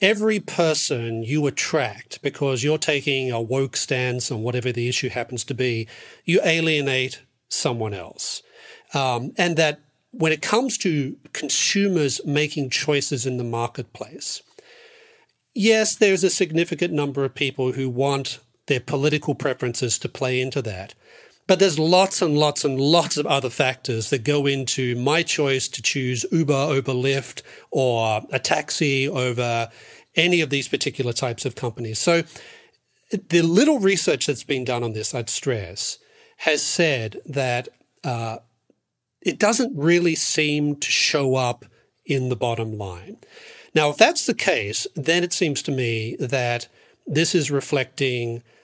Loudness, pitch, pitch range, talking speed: -22 LUFS, 140 Hz, 125-170 Hz, 150 wpm